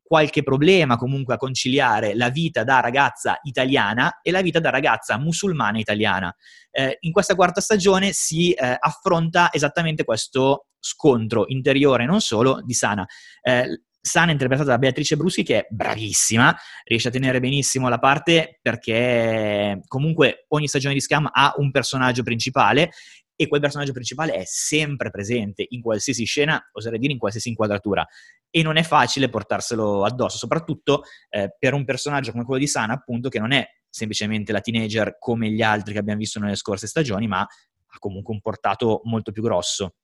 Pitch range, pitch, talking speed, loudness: 110-150 Hz, 130 Hz, 170 wpm, -21 LUFS